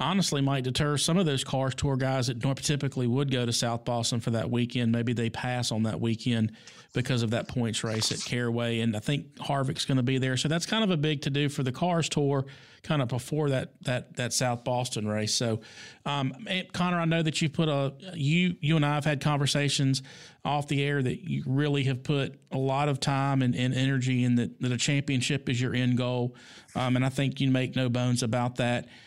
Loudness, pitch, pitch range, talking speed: -28 LUFS, 135 Hz, 125-145 Hz, 225 wpm